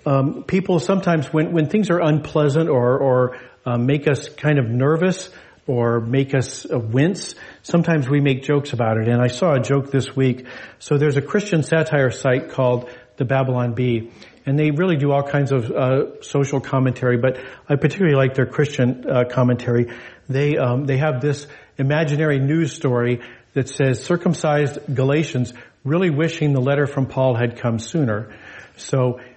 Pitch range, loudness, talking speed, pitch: 125-150 Hz, -19 LUFS, 170 wpm, 135 Hz